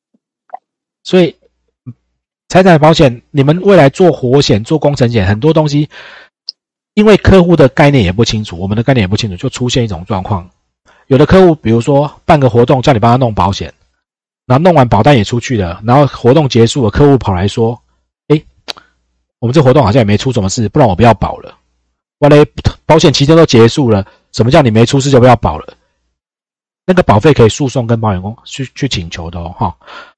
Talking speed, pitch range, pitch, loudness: 300 characters per minute, 105-150 Hz, 125 Hz, -9 LUFS